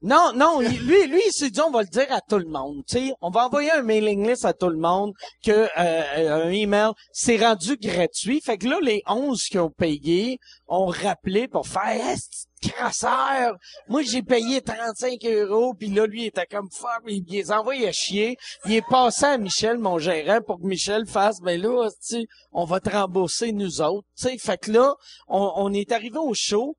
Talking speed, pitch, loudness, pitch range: 215 wpm, 215 Hz, -23 LUFS, 190-245 Hz